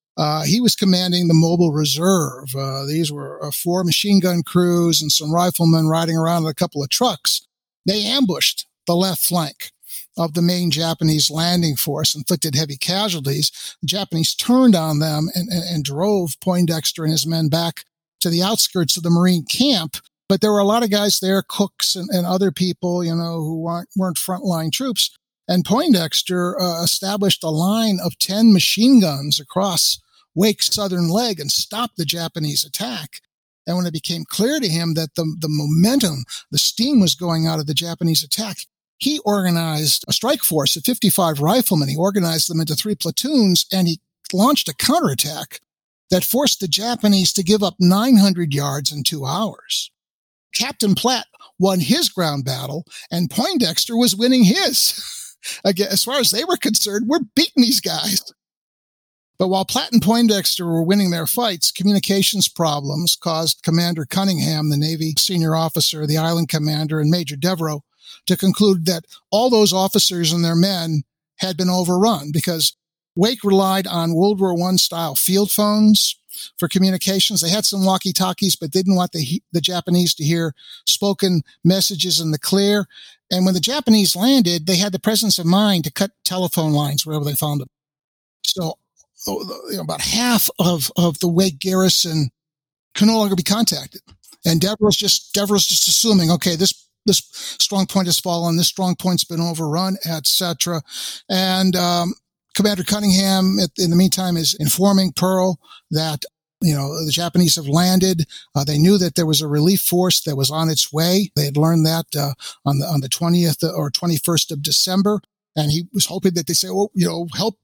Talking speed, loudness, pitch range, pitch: 180 wpm, -18 LUFS, 160-195 Hz, 175 Hz